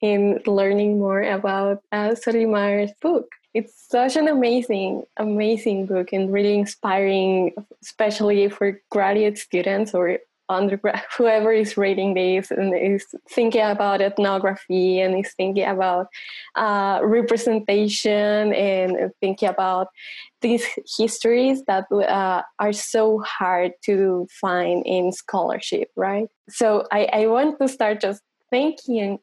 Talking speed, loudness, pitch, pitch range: 125 wpm, -21 LUFS, 205 Hz, 195-220 Hz